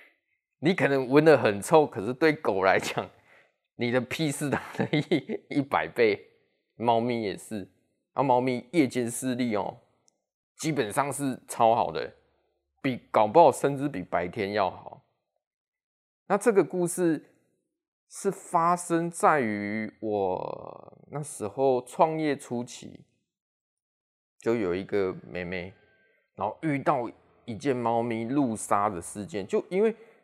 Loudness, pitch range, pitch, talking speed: -27 LUFS, 115-165 Hz, 130 Hz, 185 characters per minute